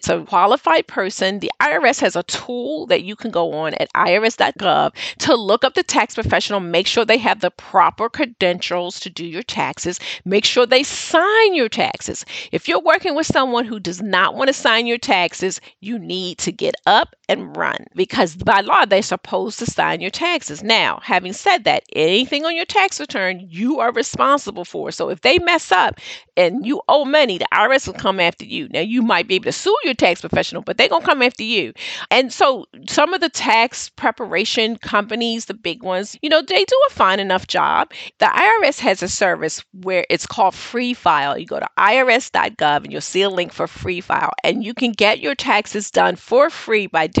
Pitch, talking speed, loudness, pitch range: 230 Hz, 210 wpm, -17 LUFS, 185-285 Hz